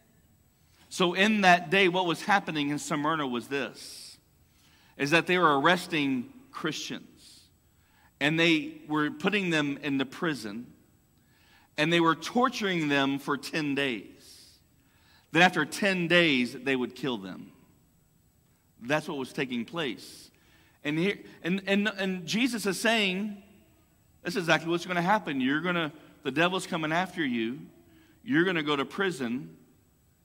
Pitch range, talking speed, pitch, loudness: 135-185 Hz, 150 wpm, 155 Hz, -27 LUFS